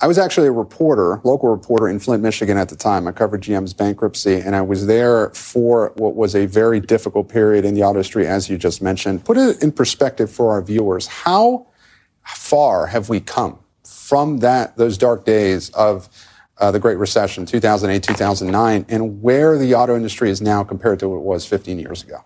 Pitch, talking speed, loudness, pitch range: 105 Hz, 200 wpm, -17 LUFS, 100-115 Hz